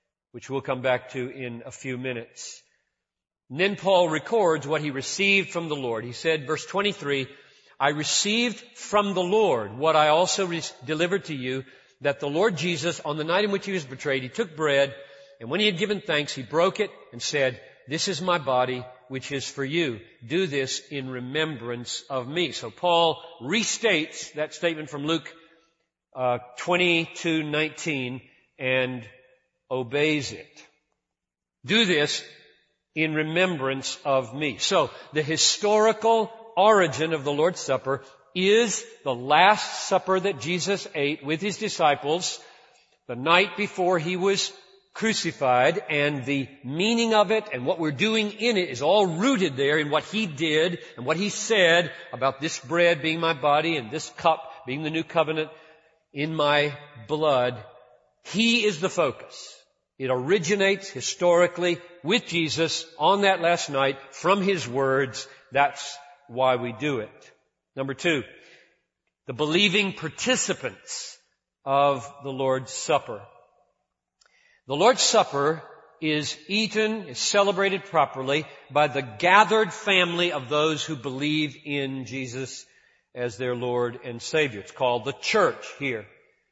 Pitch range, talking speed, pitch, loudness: 135-185 Hz, 150 wpm, 155 Hz, -24 LUFS